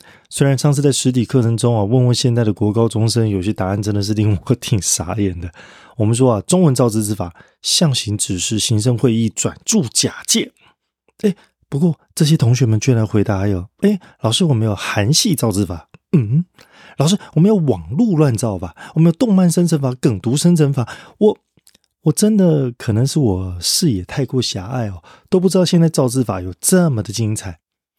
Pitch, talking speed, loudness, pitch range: 125 Hz, 285 characters per minute, -16 LUFS, 105-160 Hz